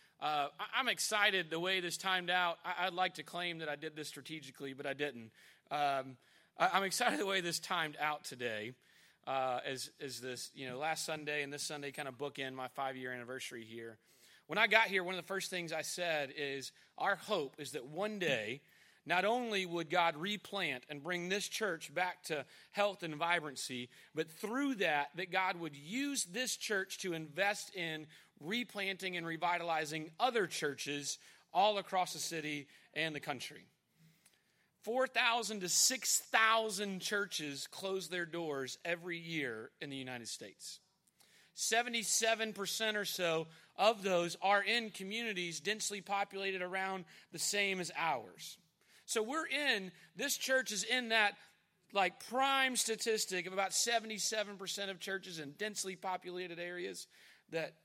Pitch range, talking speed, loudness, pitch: 155-205 Hz, 160 wpm, -36 LUFS, 180 Hz